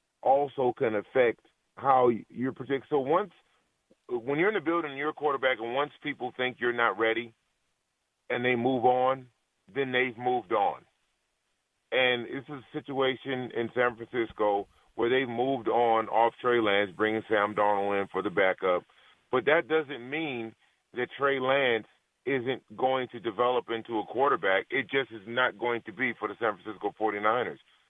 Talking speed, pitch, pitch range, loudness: 170 wpm, 125 Hz, 115-135 Hz, -28 LUFS